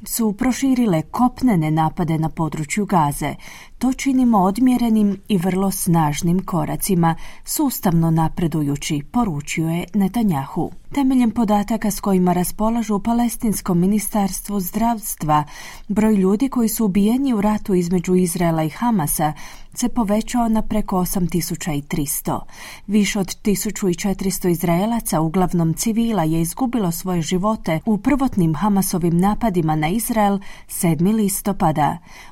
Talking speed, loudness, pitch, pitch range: 115 wpm, -19 LUFS, 195 Hz, 170-220 Hz